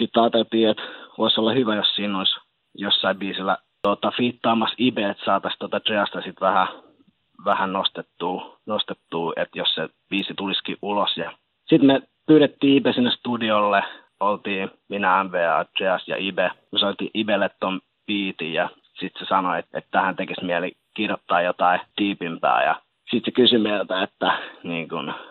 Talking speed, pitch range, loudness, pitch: 155 wpm, 100-120 Hz, -22 LUFS, 110 Hz